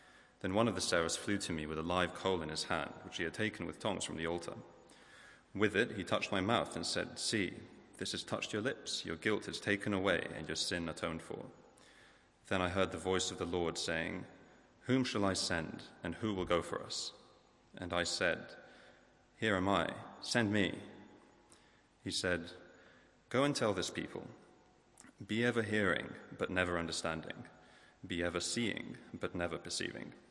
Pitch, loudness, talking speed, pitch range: 90 Hz, -37 LUFS, 185 wpm, 85-100 Hz